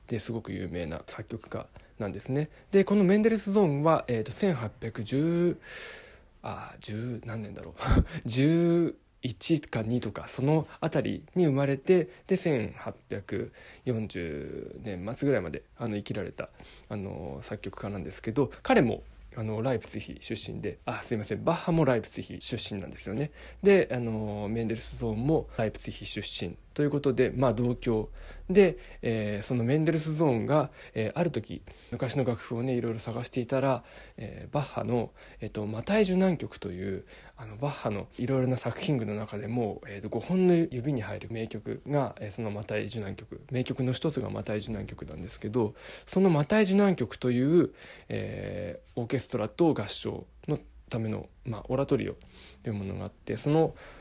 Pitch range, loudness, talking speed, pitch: 105-145 Hz, -30 LUFS, 315 characters per minute, 120 Hz